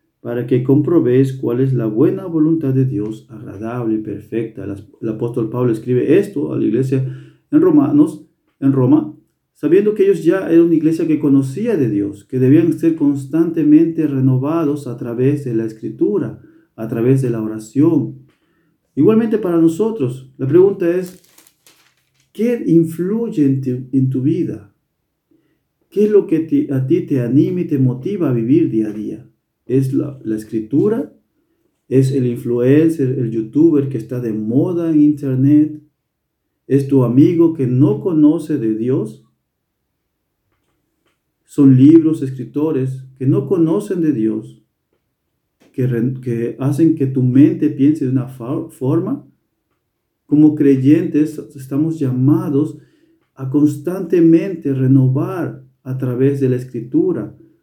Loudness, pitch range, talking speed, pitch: -16 LUFS, 125-160 Hz, 140 wpm, 140 Hz